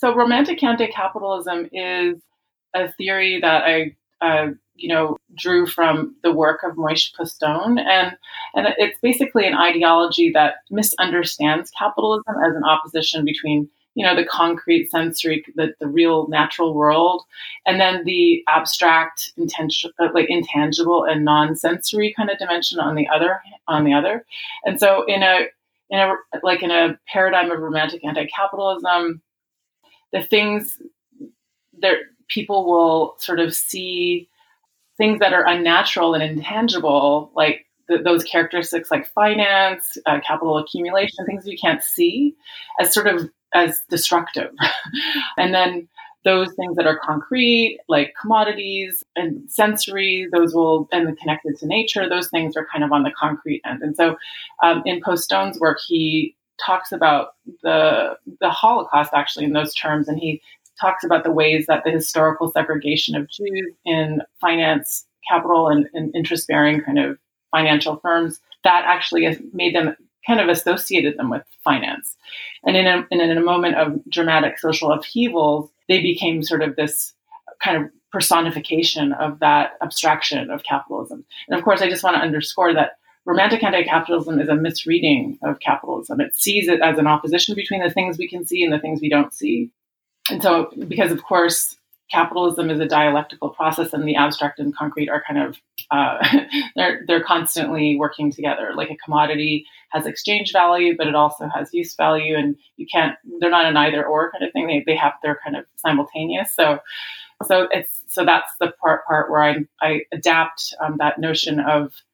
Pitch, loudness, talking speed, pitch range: 170 Hz, -19 LUFS, 165 wpm, 155-195 Hz